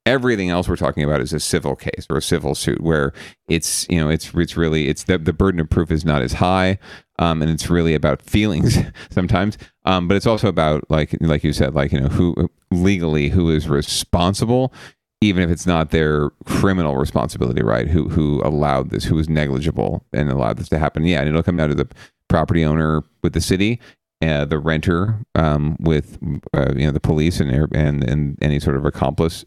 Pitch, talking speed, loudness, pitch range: 80 Hz, 210 wpm, -19 LUFS, 75-90 Hz